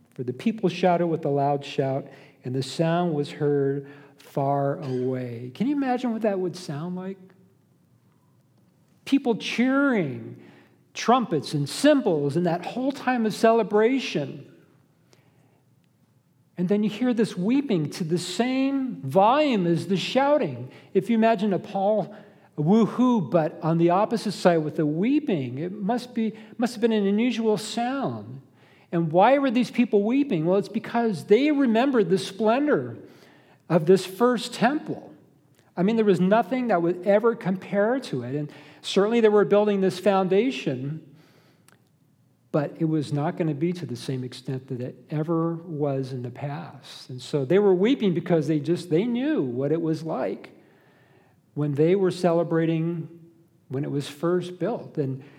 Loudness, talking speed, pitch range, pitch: -24 LUFS, 160 wpm, 145-215 Hz, 175 Hz